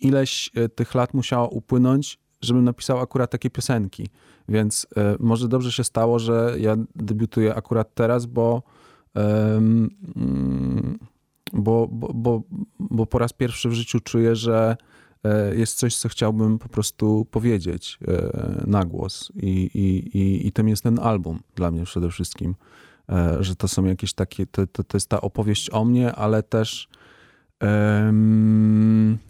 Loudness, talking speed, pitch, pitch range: -22 LUFS, 155 wpm, 110 Hz, 105-120 Hz